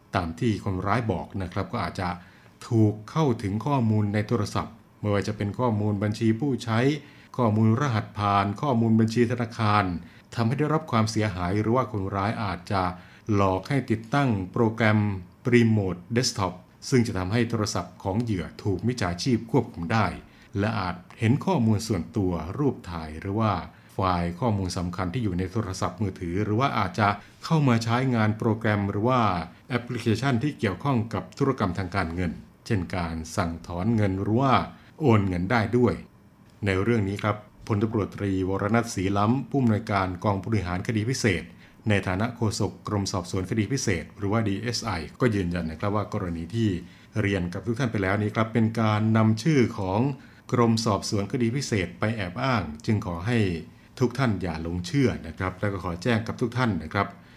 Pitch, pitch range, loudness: 105 Hz, 95-115 Hz, -26 LUFS